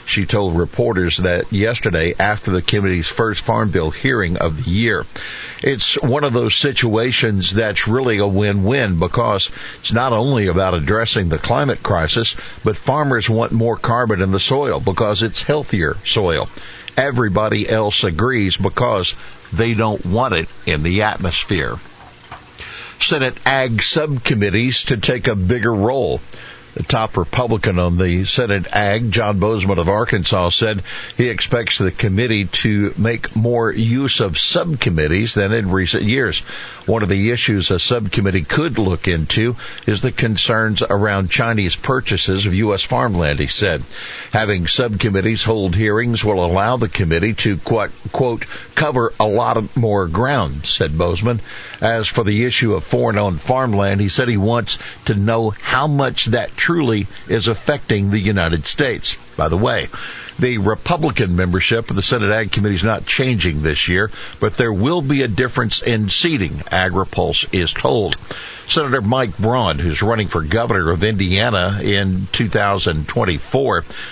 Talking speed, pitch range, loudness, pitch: 150 wpm, 95-115 Hz, -17 LUFS, 105 Hz